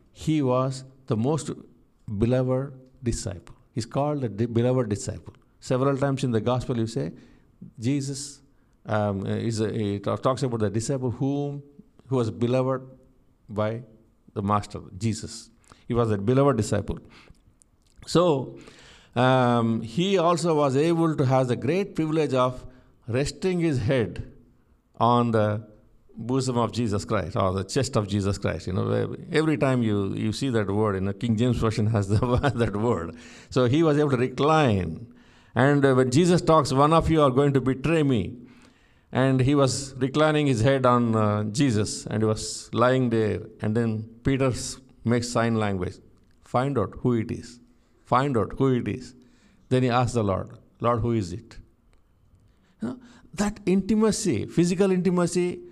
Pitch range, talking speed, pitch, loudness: 110-135 Hz, 160 wpm, 120 Hz, -24 LUFS